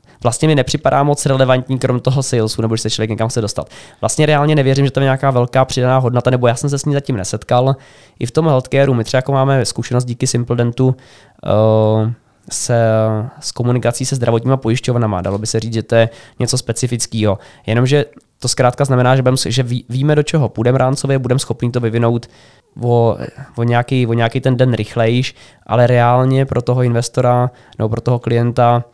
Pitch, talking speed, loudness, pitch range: 125 Hz, 185 wpm, -15 LUFS, 115-130 Hz